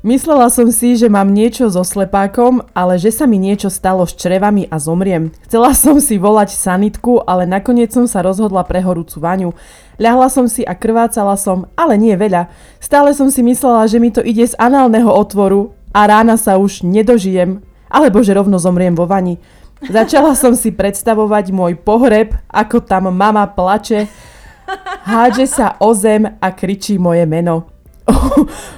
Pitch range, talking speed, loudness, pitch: 190-235 Hz, 165 wpm, -11 LUFS, 210 Hz